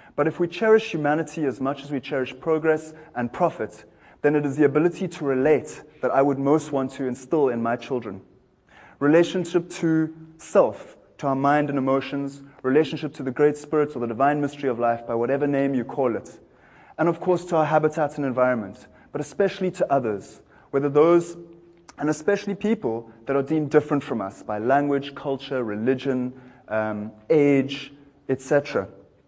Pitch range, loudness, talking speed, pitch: 130-155 Hz, -23 LUFS, 175 wpm, 140 Hz